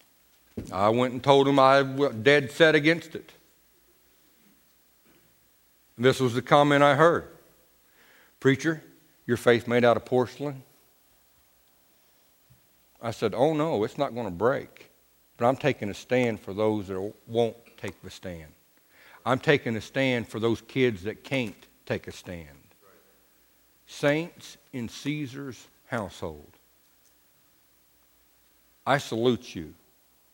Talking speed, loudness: 125 wpm, -25 LUFS